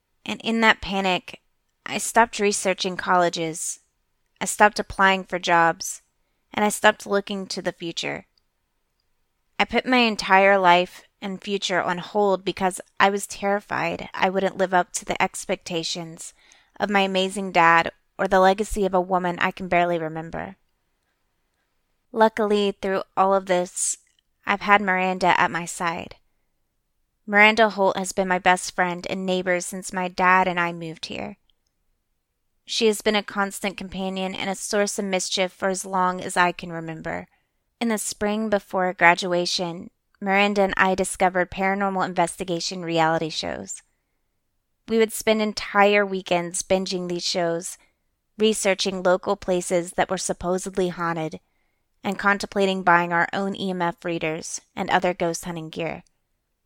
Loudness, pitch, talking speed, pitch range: -22 LUFS, 185 Hz, 145 wpm, 175-200 Hz